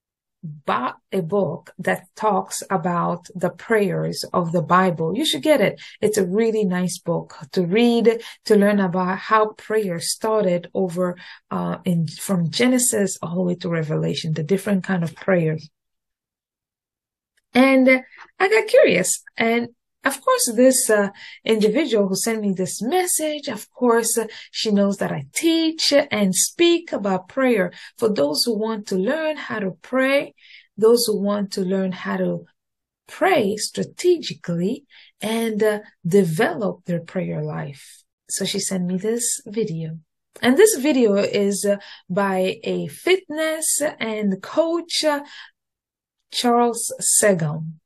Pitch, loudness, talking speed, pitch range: 205 Hz, -20 LUFS, 140 wpm, 185-245 Hz